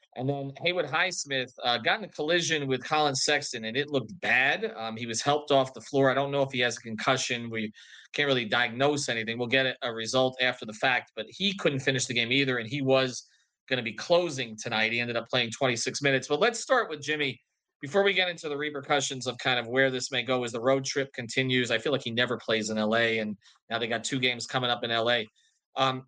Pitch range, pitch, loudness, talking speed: 120-140 Hz, 130 Hz, -27 LUFS, 245 wpm